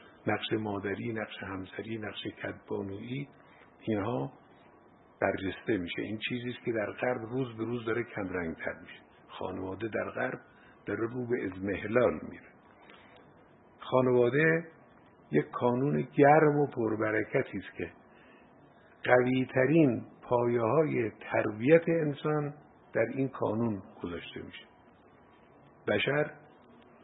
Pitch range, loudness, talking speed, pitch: 110-135 Hz, -31 LUFS, 115 wpm, 120 Hz